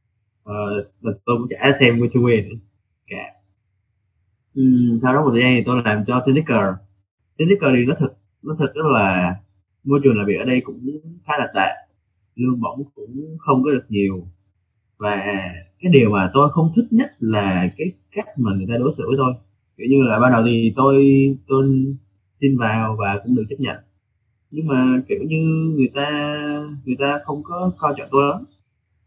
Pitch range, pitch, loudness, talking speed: 100-140 Hz, 125 Hz, -18 LUFS, 190 wpm